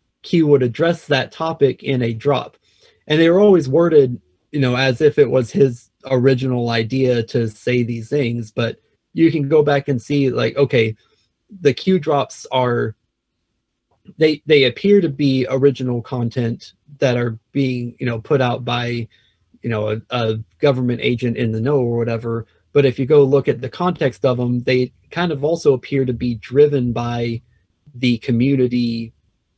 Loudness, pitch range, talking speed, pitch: -18 LUFS, 115-145 Hz, 175 wpm, 125 Hz